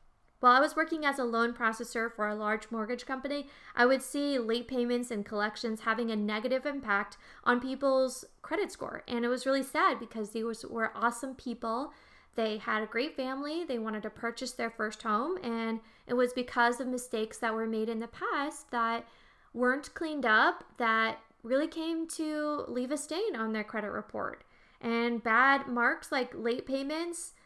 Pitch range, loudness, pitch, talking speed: 225-280 Hz, -32 LUFS, 245 Hz, 180 wpm